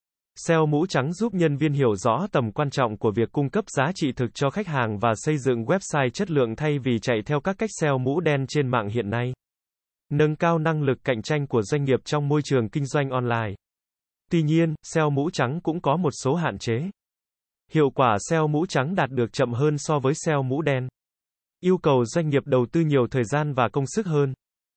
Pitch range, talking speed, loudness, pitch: 125-155 Hz, 225 wpm, -24 LUFS, 145 Hz